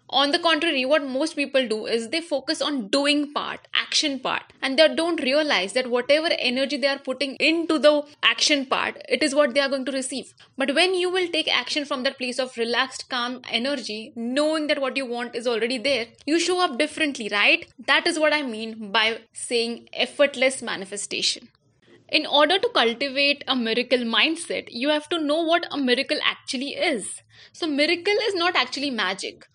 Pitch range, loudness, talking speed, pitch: 250-310 Hz, -22 LUFS, 190 wpm, 280 Hz